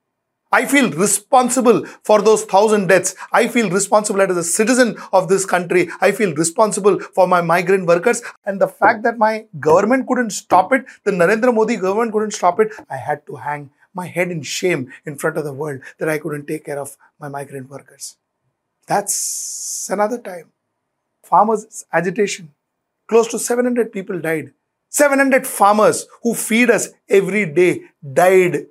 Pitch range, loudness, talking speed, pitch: 170-220 Hz, -16 LUFS, 165 wpm, 195 Hz